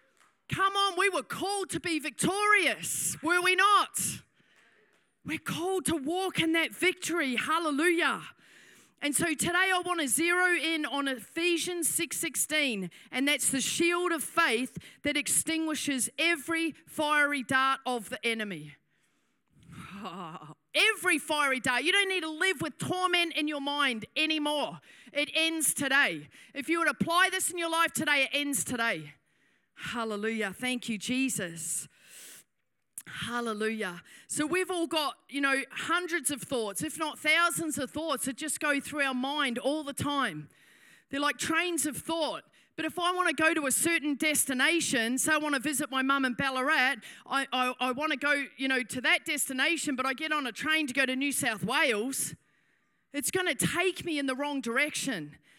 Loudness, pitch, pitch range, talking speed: -28 LUFS, 290 Hz, 260-330 Hz, 170 wpm